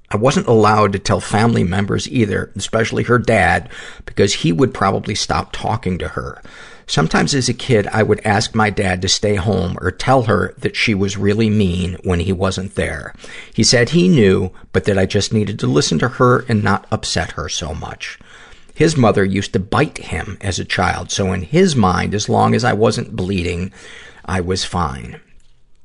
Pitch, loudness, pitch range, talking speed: 100 Hz, -16 LUFS, 95-115 Hz, 195 wpm